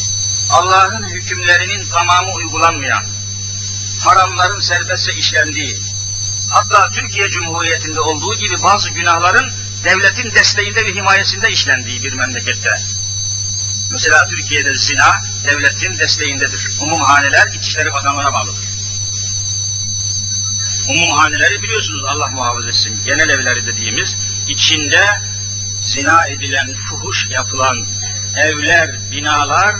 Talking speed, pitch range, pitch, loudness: 90 wpm, 100-105 Hz, 100 Hz, -13 LUFS